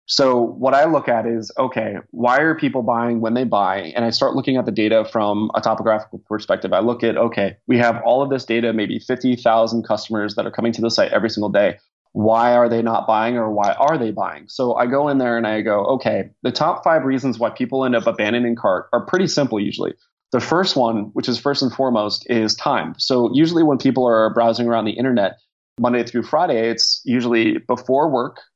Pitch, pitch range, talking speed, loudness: 115 Hz, 110-130 Hz, 225 wpm, -18 LUFS